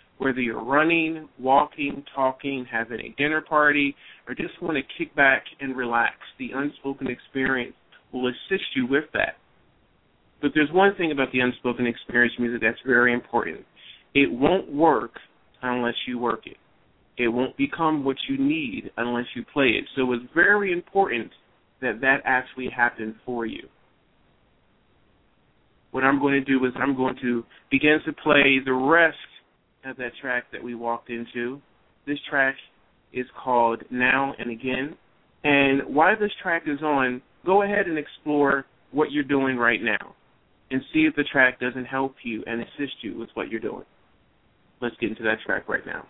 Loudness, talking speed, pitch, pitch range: -24 LUFS, 170 wpm, 135 Hz, 120-150 Hz